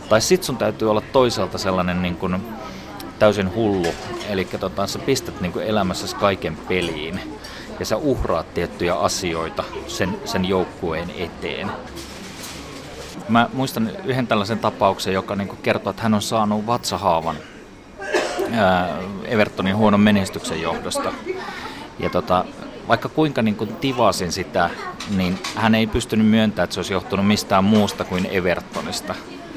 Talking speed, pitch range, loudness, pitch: 140 wpm, 95-115 Hz, -21 LUFS, 105 Hz